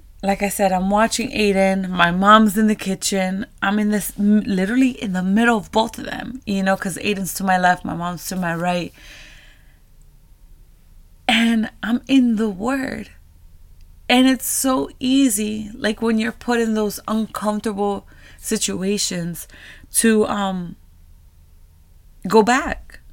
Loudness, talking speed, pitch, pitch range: -19 LUFS, 145 wpm, 205 Hz, 185-225 Hz